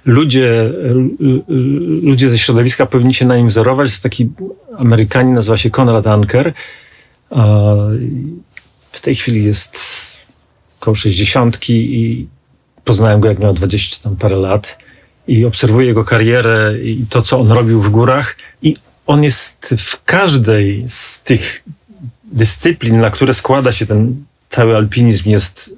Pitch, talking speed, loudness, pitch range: 120 Hz, 140 wpm, -11 LUFS, 110-130 Hz